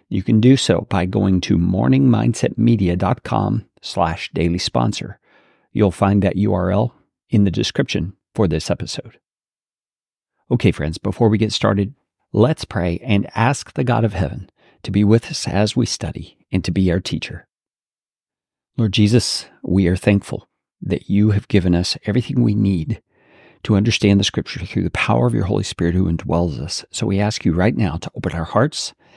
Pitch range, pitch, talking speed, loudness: 90-115 Hz, 100 Hz, 175 wpm, -18 LUFS